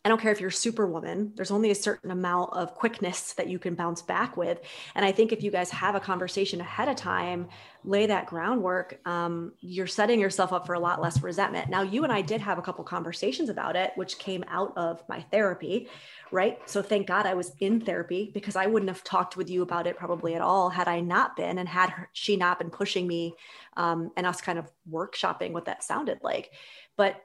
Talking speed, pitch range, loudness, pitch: 225 wpm, 175-200 Hz, -29 LUFS, 185 Hz